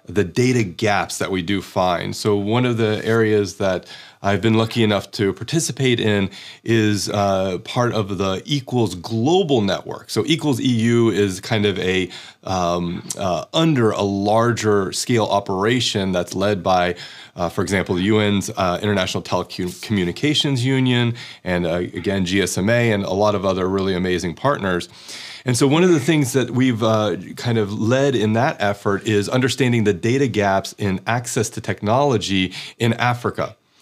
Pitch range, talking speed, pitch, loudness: 95-120 Hz, 165 wpm, 105 Hz, -19 LUFS